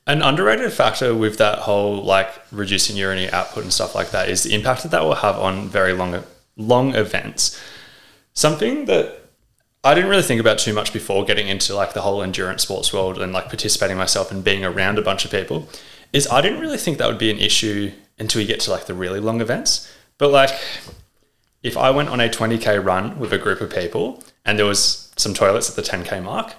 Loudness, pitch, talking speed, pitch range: -19 LUFS, 105 Hz, 220 wpm, 95-120 Hz